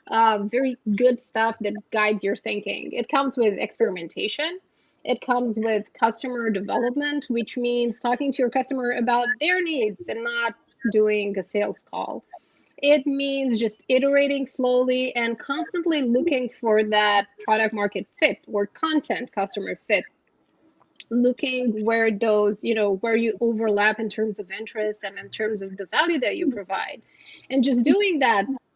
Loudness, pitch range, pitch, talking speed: -23 LUFS, 215-260 Hz, 235 Hz, 155 wpm